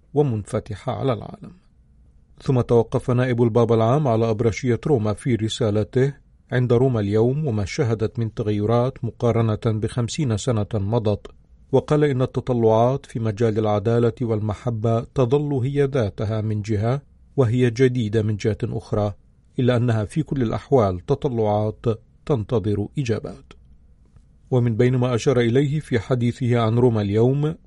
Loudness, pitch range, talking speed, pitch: -21 LUFS, 110-130 Hz, 130 wpm, 115 Hz